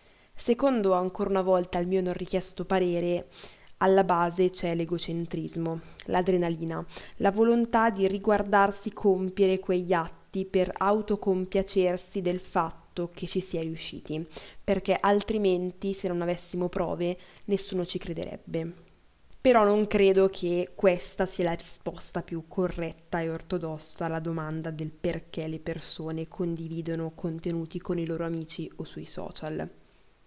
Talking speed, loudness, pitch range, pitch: 130 wpm, -28 LUFS, 170-190 Hz, 180 Hz